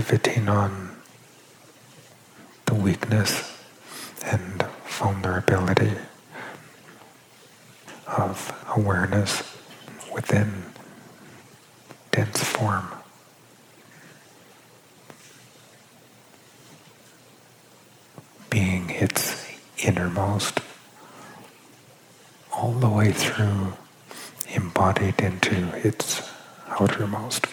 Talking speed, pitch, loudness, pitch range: 50 wpm, 100 Hz, -25 LUFS, 95-110 Hz